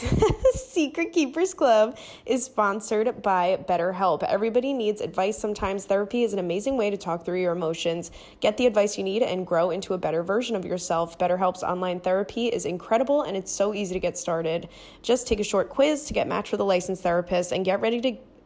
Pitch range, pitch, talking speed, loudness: 180-230 Hz, 195 Hz, 200 wpm, -25 LUFS